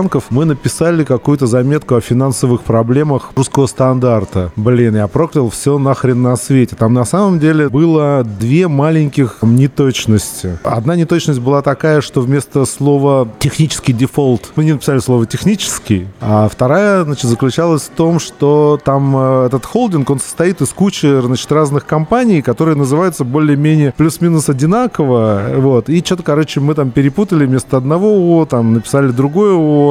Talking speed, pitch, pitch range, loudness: 145 wpm, 140 Hz, 125-155 Hz, -12 LUFS